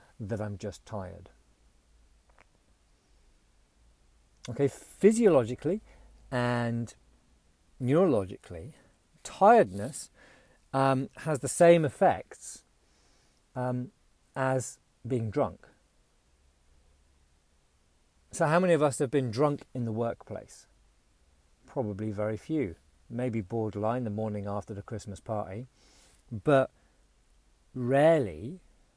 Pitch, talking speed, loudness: 110 Hz, 85 wpm, -29 LUFS